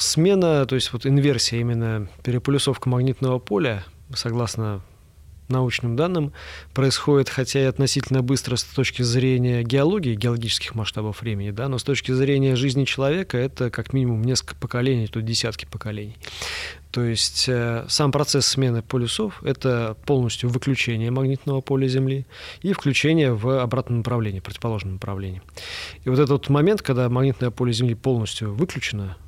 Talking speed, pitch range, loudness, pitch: 145 wpm, 115-135 Hz, -22 LUFS, 125 Hz